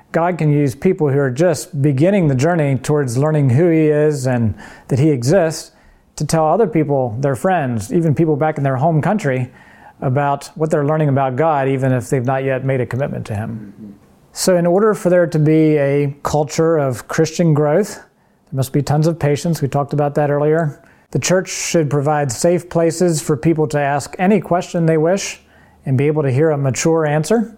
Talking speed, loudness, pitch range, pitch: 200 wpm, -16 LUFS, 140-165 Hz, 150 Hz